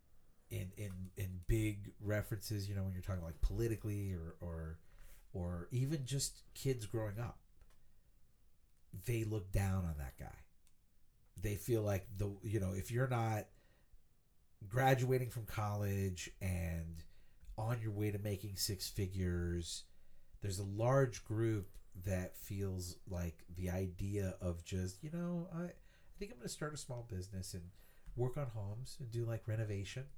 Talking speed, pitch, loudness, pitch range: 150 wpm, 100 Hz, -41 LUFS, 95-115 Hz